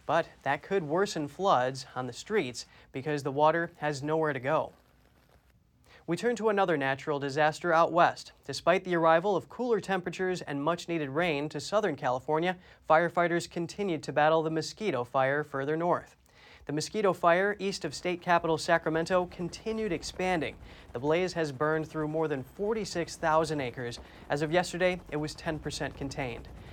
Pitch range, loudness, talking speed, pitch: 150-180 Hz, -30 LUFS, 160 wpm, 160 Hz